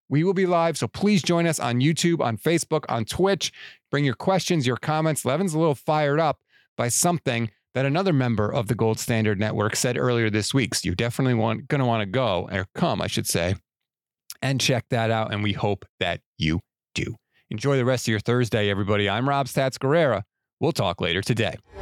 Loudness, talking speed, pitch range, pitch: -24 LUFS, 210 wpm, 110-150 Hz, 125 Hz